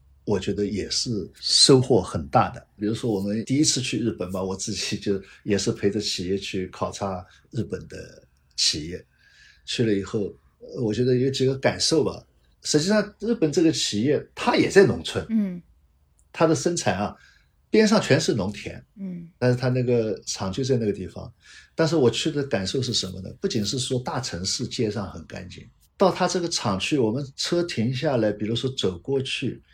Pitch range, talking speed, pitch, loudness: 100-150 Hz, 270 characters per minute, 115 Hz, -24 LUFS